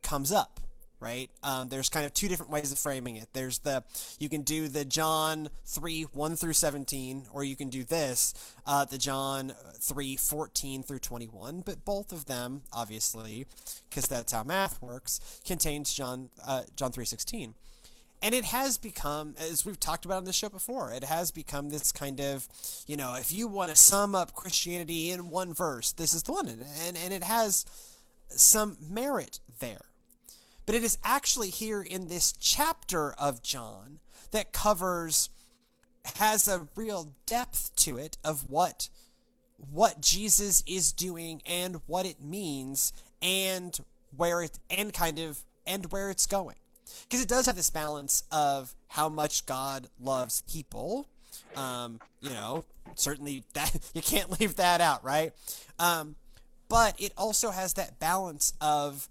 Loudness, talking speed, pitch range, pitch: -29 LUFS, 165 wpm, 135-190 Hz, 155 Hz